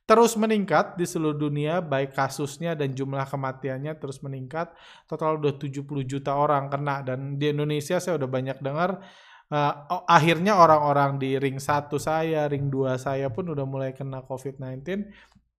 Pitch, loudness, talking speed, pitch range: 145 Hz, -25 LUFS, 155 wpm, 135-165 Hz